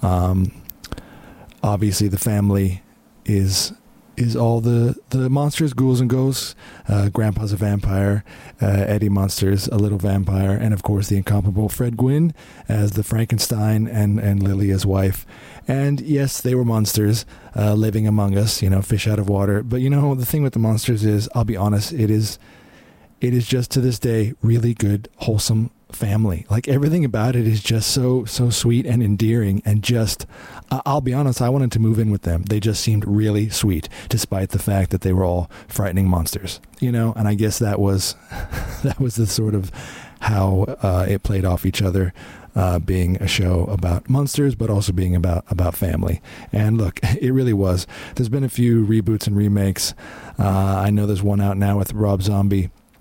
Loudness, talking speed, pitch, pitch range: -20 LUFS, 190 wpm, 105 Hz, 100-120 Hz